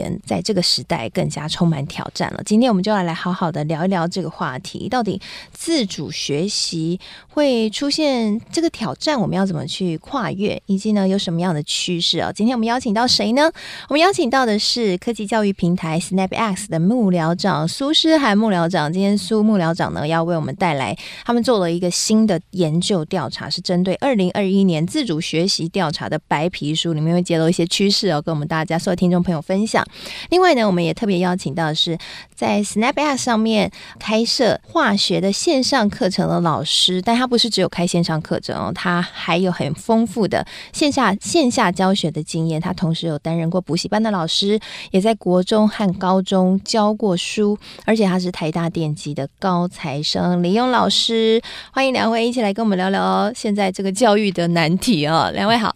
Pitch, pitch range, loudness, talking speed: 190 Hz, 170-220 Hz, -18 LUFS, 315 characters per minute